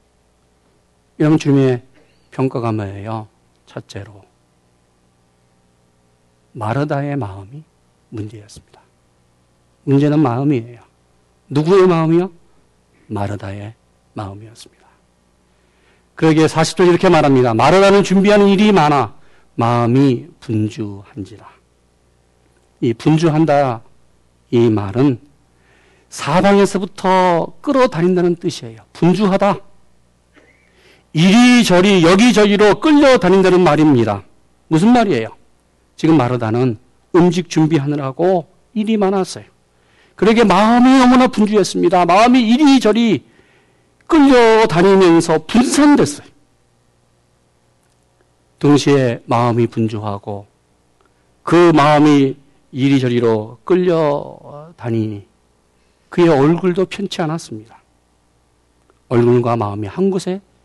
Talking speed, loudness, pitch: 235 characters per minute, -13 LUFS, 120 Hz